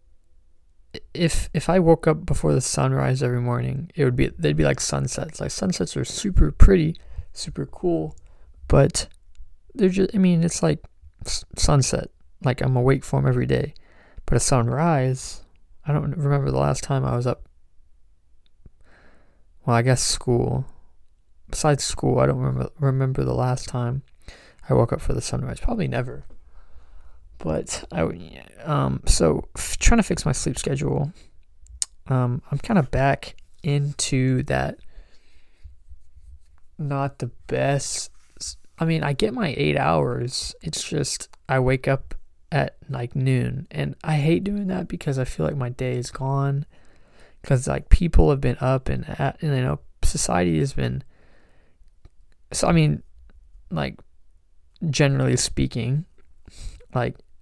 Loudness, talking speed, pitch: -23 LUFS, 145 wpm, 90 Hz